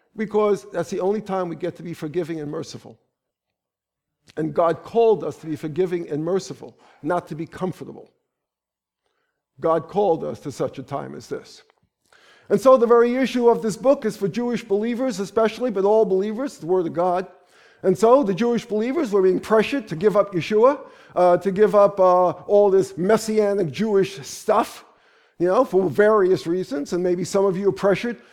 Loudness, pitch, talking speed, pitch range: -21 LUFS, 195 Hz, 185 wpm, 170-215 Hz